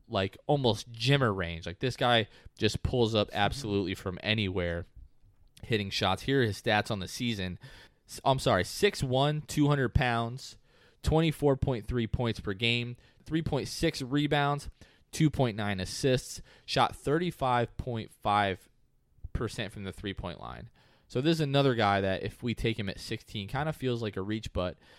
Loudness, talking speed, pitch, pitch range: -30 LUFS, 145 wpm, 115 Hz, 100-135 Hz